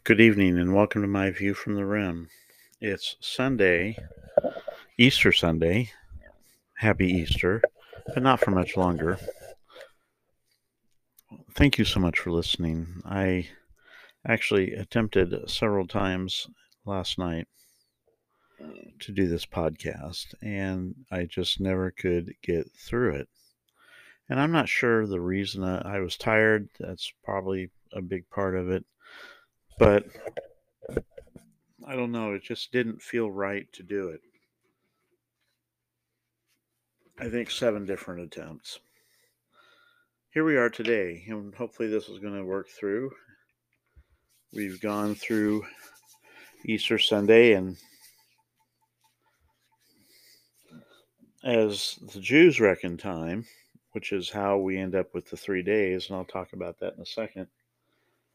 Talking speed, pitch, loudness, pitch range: 125 wpm, 100 Hz, -26 LUFS, 90-115 Hz